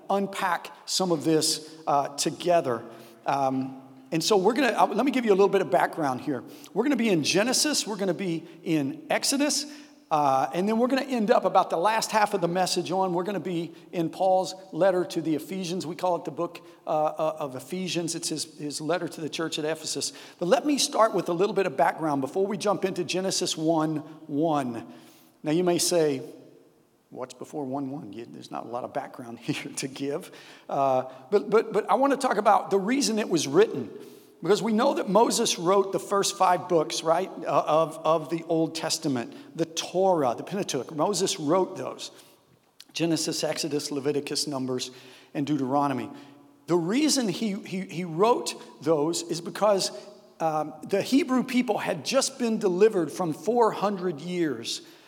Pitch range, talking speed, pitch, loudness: 155-205 Hz, 190 wpm, 175 Hz, -26 LUFS